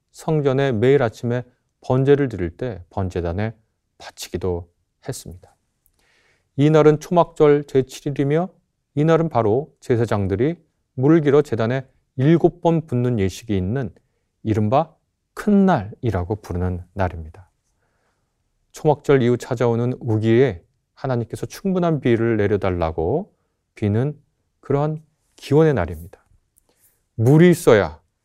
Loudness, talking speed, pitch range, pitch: -20 LUFS, 255 characters per minute, 100-145 Hz, 125 Hz